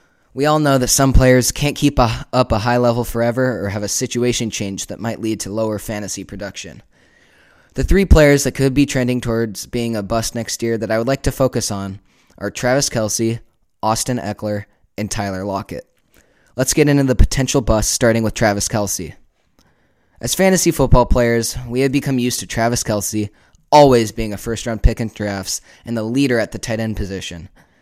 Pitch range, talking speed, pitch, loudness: 105-130 Hz, 195 wpm, 115 Hz, -17 LUFS